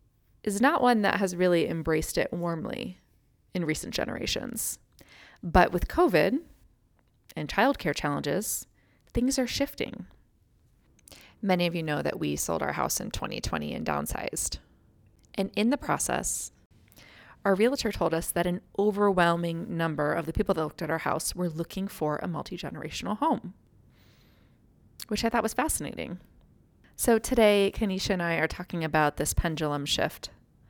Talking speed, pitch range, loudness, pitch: 150 wpm, 160-210 Hz, -28 LUFS, 180 Hz